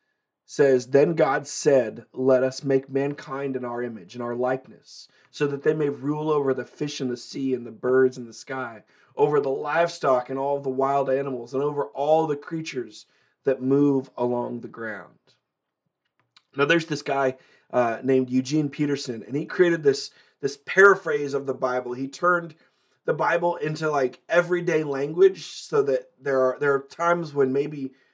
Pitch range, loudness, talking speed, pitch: 130-155 Hz, -24 LUFS, 175 wpm, 140 Hz